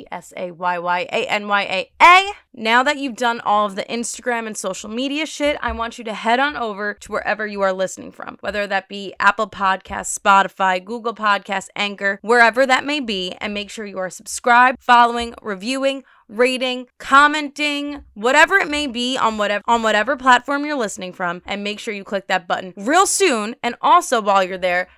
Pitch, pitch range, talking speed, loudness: 225 Hz, 200-255 Hz, 200 wpm, -18 LUFS